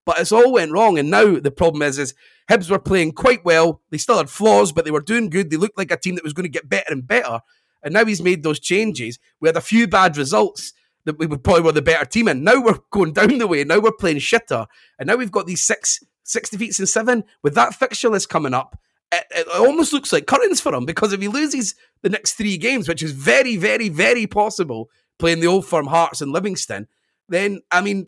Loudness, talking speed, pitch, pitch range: -18 LUFS, 250 wpm, 190 Hz, 165-225 Hz